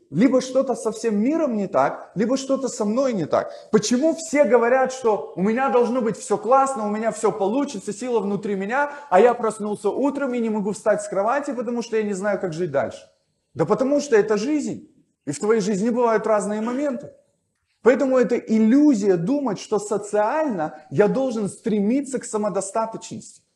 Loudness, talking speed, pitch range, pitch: -21 LUFS, 180 wpm, 210-260 Hz, 220 Hz